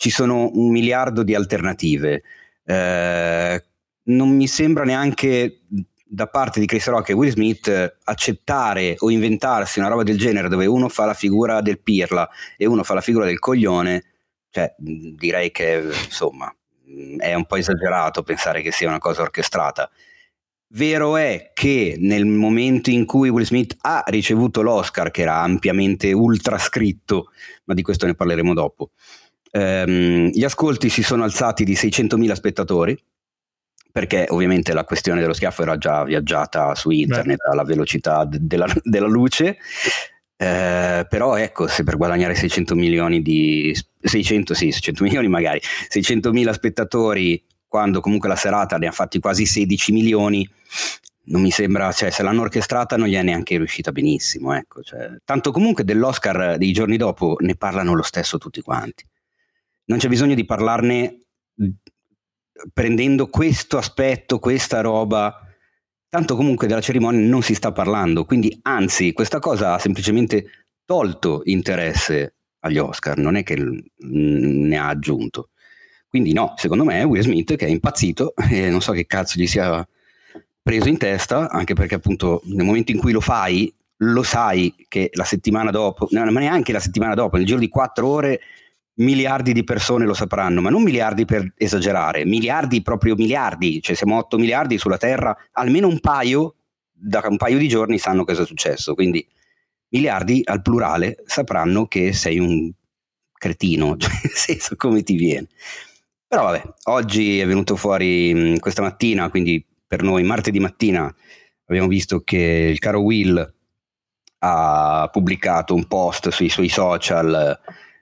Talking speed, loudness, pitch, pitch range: 155 wpm, -19 LUFS, 105 Hz, 90-115 Hz